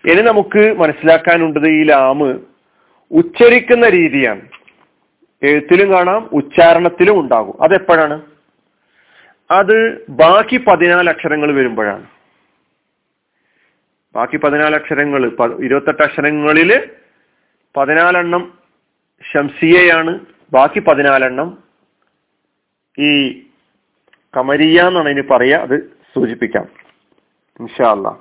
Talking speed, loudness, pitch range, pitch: 70 wpm, -11 LUFS, 145-180 Hz, 160 Hz